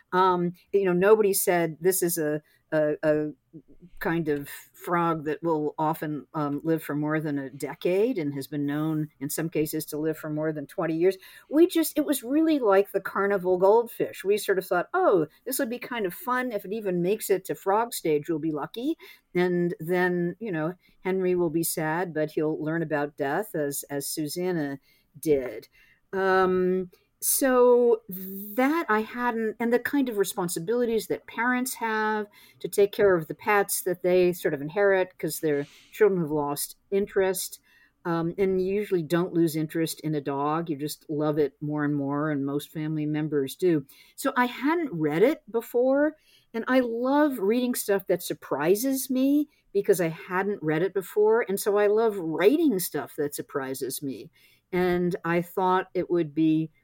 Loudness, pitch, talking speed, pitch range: -26 LUFS, 180 Hz, 180 wpm, 155-215 Hz